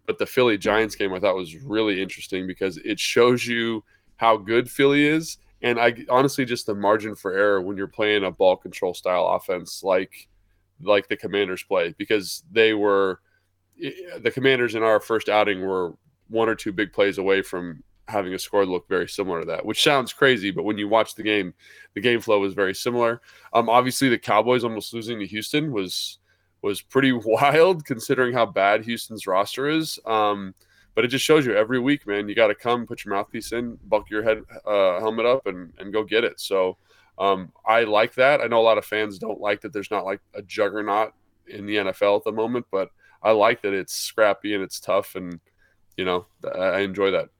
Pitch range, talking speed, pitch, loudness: 95-120 Hz, 210 wpm, 105 Hz, -22 LUFS